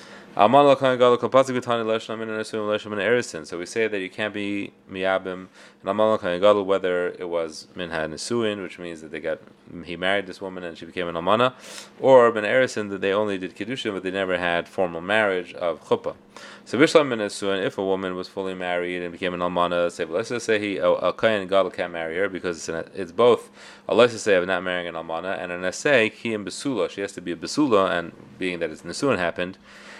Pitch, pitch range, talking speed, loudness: 95 Hz, 90-110 Hz, 170 wpm, -23 LUFS